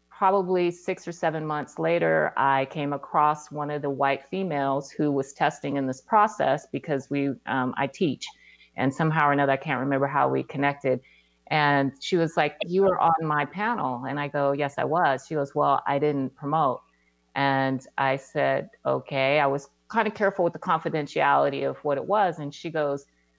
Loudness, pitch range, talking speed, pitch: -25 LUFS, 135-160 Hz, 190 wpm, 140 Hz